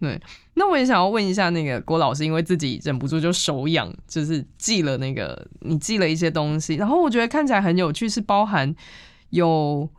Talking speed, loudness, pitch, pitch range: 315 characters per minute, -21 LUFS, 165 Hz, 155-205 Hz